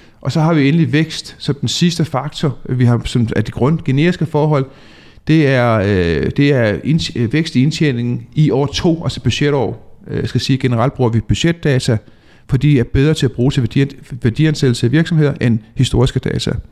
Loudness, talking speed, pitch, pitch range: -15 LUFS, 195 wpm, 135 Hz, 120-150 Hz